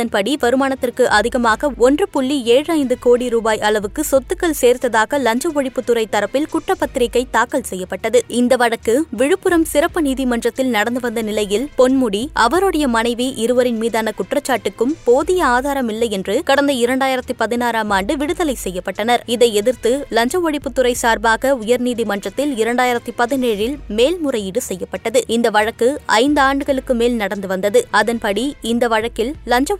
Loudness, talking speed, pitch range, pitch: -17 LUFS, 125 wpm, 225-275 Hz, 245 Hz